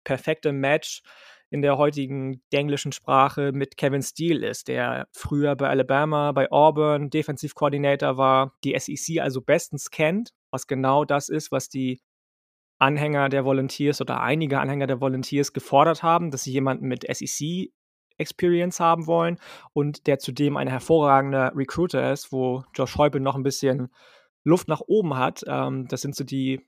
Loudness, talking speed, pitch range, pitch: -23 LUFS, 155 wpm, 135-150 Hz, 140 Hz